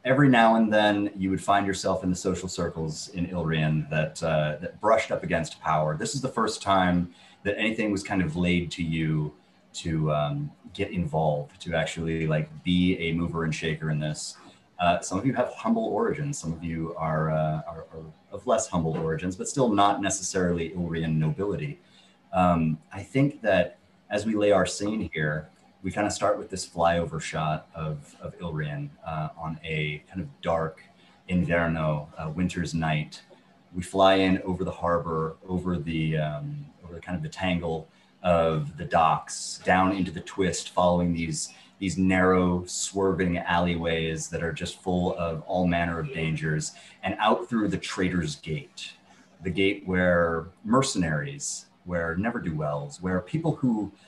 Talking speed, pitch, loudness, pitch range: 170 wpm, 85 Hz, -27 LUFS, 80-95 Hz